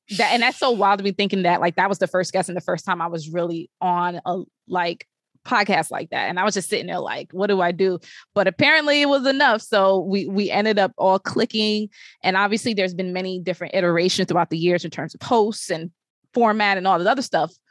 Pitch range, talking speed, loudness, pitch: 180-210 Hz, 245 wpm, -21 LUFS, 190 Hz